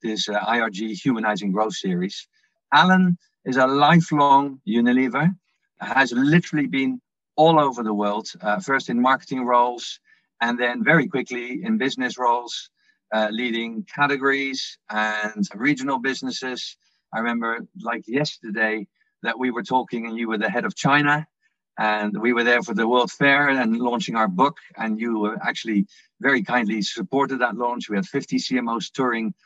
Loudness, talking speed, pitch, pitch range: -22 LUFS, 155 wpm, 125 Hz, 115-145 Hz